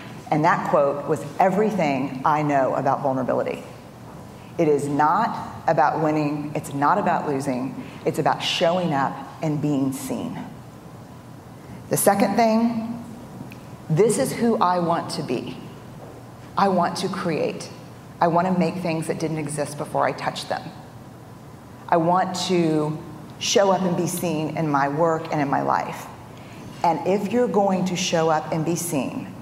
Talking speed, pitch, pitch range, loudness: 155 wpm, 165 Hz, 150-180 Hz, -22 LUFS